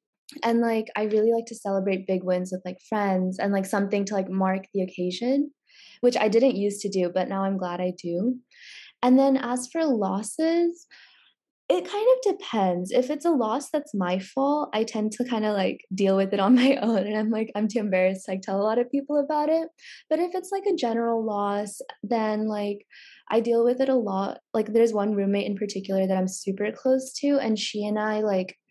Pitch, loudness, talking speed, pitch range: 215 Hz, -25 LUFS, 220 wpm, 195-255 Hz